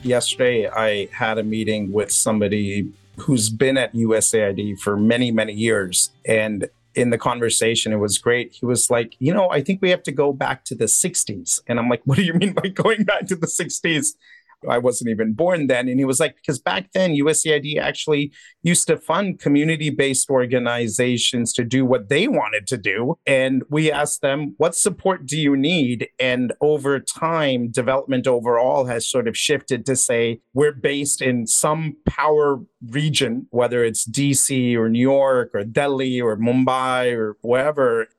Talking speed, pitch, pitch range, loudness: 180 wpm, 130 Hz, 115-150 Hz, -19 LUFS